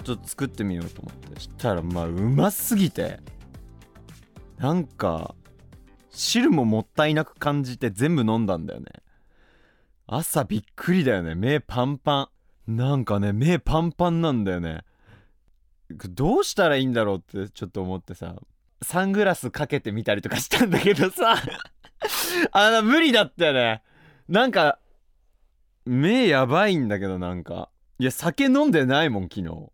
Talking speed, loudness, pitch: 310 characters per minute, -23 LUFS, 125 Hz